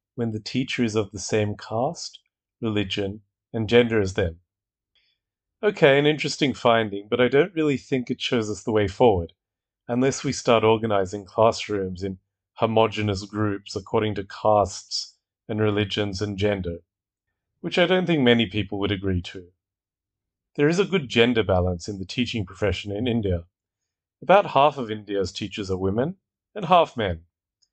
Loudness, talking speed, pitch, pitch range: -23 LUFS, 160 wpm, 105 Hz, 100-120 Hz